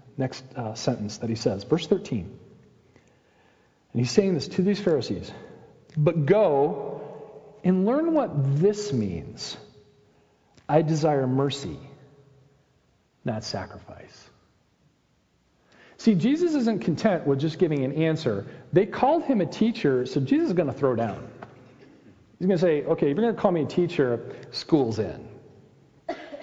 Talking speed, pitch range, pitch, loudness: 145 wpm, 135-200 Hz, 155 Hz, -25 LUFS